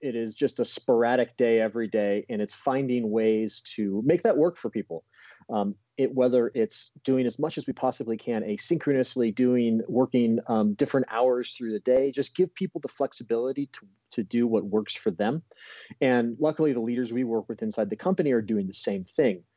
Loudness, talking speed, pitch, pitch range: -26 LUFS, 200 wpm, 120 Hz, 110-135 Hz